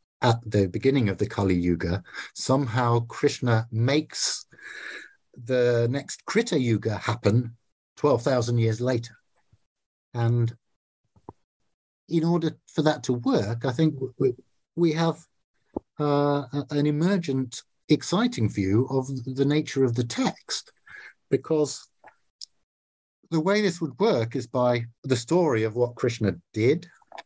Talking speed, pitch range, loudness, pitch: 120 wpm, 115-145 Hz, -25 LUFS, 125 Hz